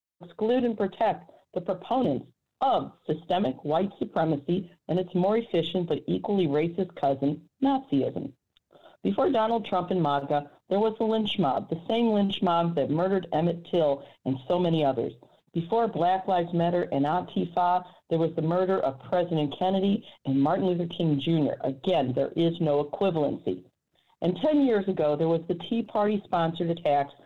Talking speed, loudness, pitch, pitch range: 165 wpm, -27 LUFS, 175 Hz, 155-195 Hz